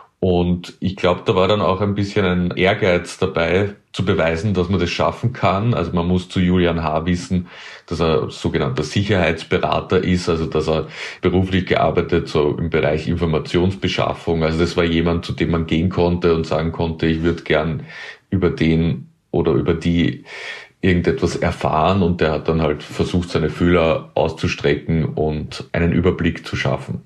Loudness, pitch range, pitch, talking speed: -19 LUFS, 80-90 Hz, 85 Hz, 170 wpm